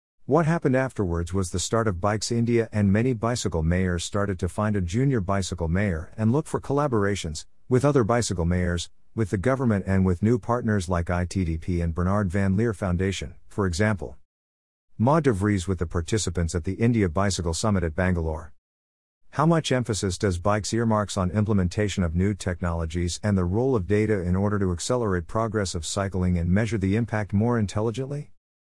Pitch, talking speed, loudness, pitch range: 100 Hz, 180 wpm, -25 LUFS, 90-110 Hz